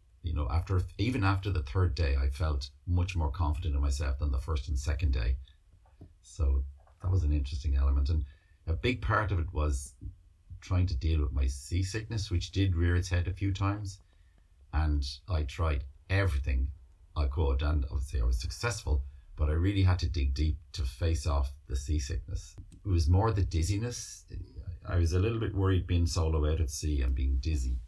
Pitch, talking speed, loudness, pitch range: 80 Hz, 195 wpm, -32 LUFS, 75-90 Hz